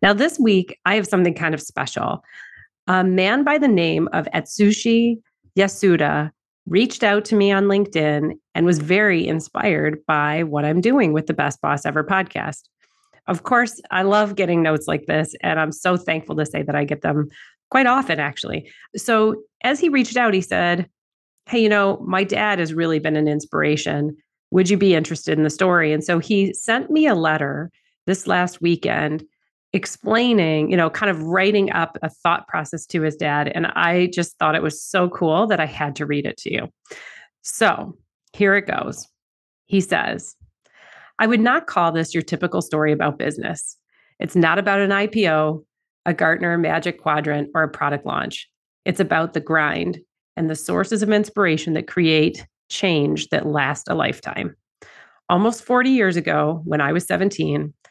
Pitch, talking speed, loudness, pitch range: 175 Hz, 180 wpm, -19 LUFS, 155-205 Hz